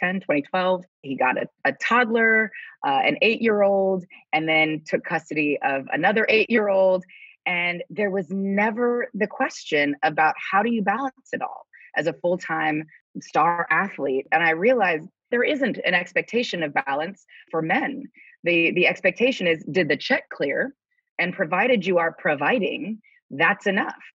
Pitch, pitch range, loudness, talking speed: 195 Hz, 165-240 Hz, -22 LUFS, 160 wpm